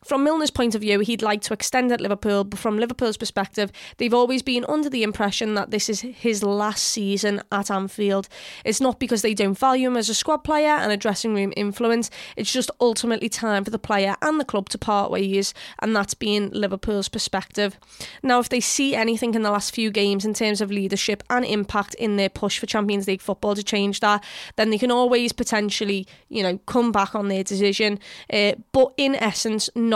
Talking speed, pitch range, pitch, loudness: 210 wpm, 205-235 Hz, 215 Hz, -22 LUFS